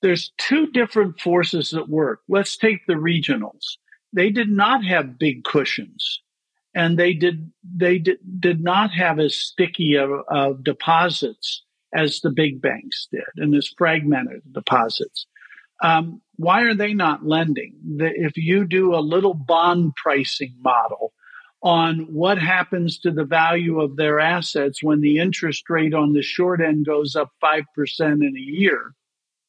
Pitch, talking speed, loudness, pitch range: 165 Hz, 155 wpm, -20 LUFS, 150-185 Hz